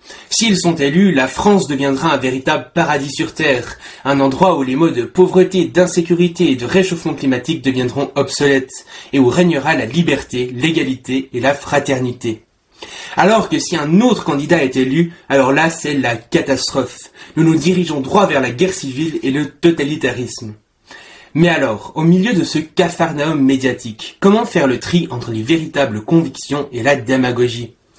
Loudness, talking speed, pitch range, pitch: -15 LUFS, 165 wpm, 130-170 Hz, 145 Hz